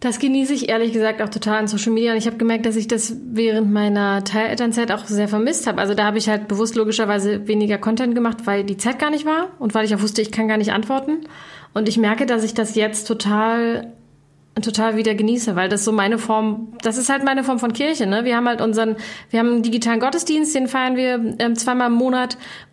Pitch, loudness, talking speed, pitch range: 225 Hz, -19 LUFS, 235 wpm, 215-240 Hz